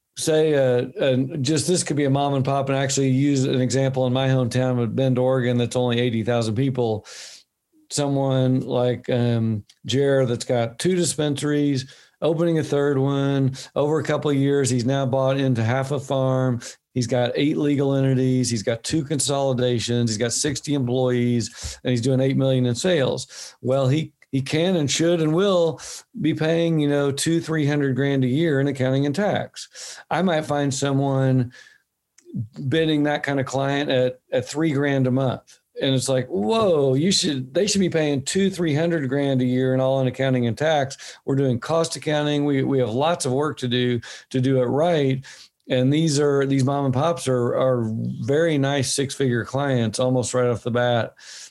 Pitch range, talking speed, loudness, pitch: 125-145 Hz, 190 wpm, -22 LUFS, 135 Hz